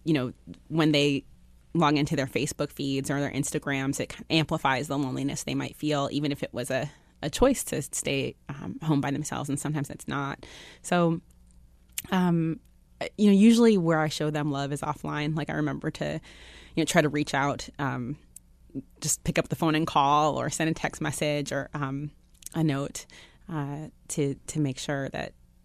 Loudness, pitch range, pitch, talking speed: -27 LUFS, 135-155 Hz, 145 Hz, 190 wpm